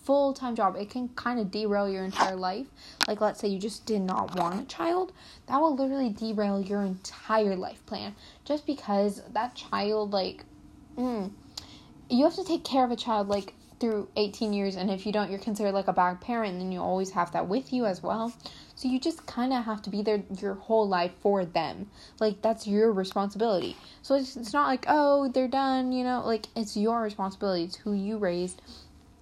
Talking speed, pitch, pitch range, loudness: 210 wpm, 215 Hz, 195-250 Hz, -29 LUFS